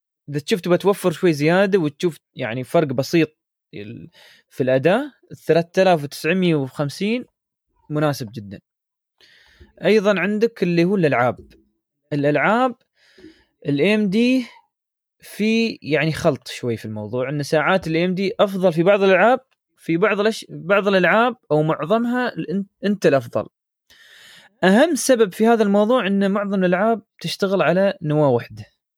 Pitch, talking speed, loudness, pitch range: 185 Hz, 115 wpm, -19 LUFS, 150-215 Hz